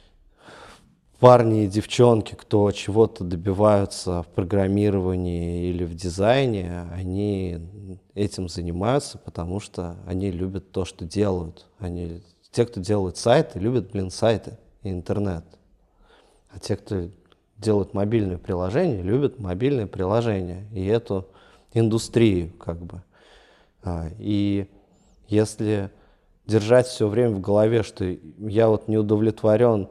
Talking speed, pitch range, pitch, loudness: 115 wpm, 90-110 Hz, 100 Hz, -23 LUFS